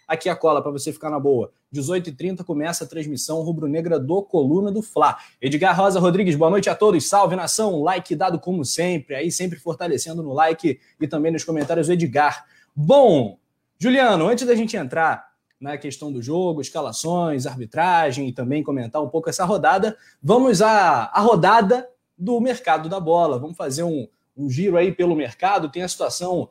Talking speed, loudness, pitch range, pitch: 180 wpm, -20 LUFS, 150-185 Hz, 165 Hz